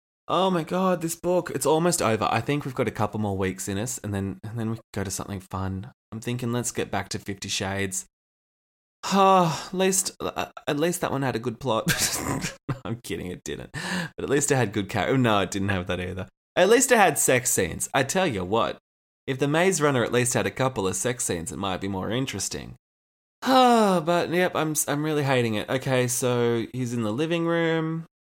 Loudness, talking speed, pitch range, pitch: -25 LUFS, 225 wpm, 100-155 Hz, 120 Hz